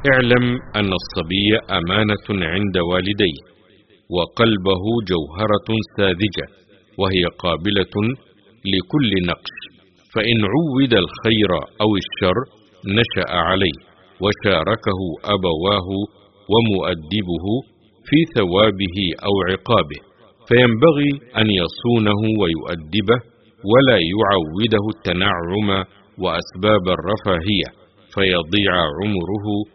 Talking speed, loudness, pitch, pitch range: 75 wpm, -18 LUFS, 105 Hz, 95-110 Hz